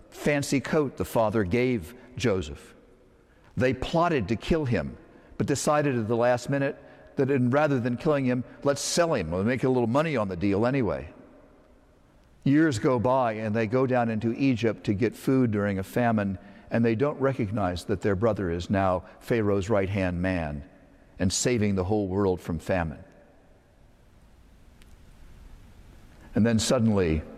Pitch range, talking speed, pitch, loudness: 100-130 Hz, 160 wpm, 115 Hz, -26 LUFS